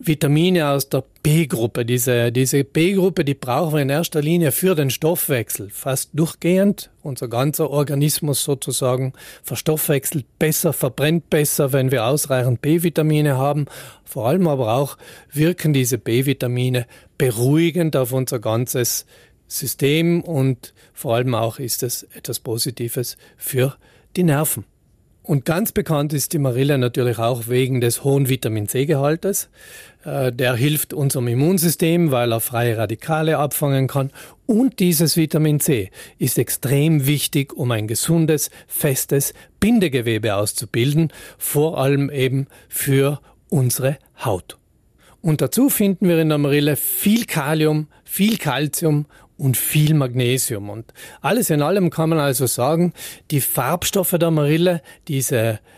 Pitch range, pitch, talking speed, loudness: 125-160 Hz, 140 Hz, 130 wpm, -19 LUFS